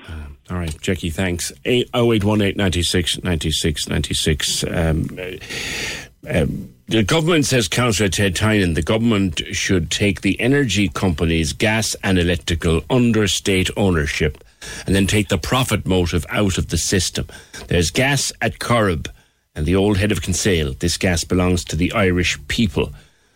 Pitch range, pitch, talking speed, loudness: 85-105 Hz, 95 Hz, 135 wpm, -19 LUFS